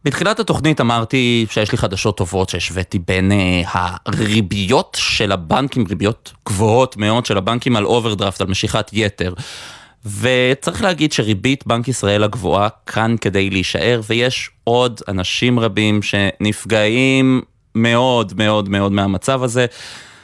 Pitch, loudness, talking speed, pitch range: 110 Hz, -16 LUFS, 125 wpm, 100-125 Hz